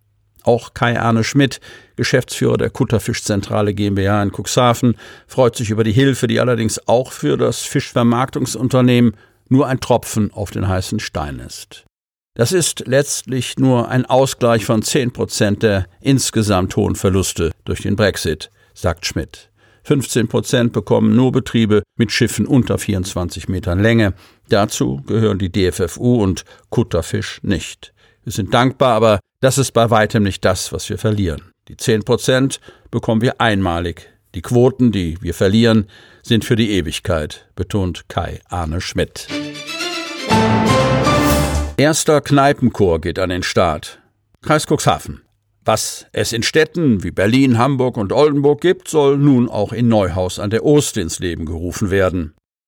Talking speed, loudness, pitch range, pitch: 145 wpm, -16 LUFS, 100-130 Hz, 110 Hz